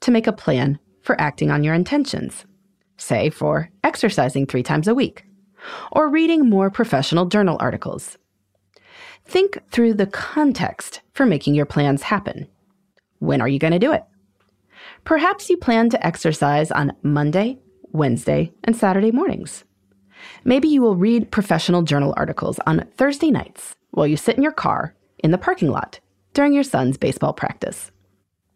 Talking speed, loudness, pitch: 155 wpm, -19 LUFS, 195 Hz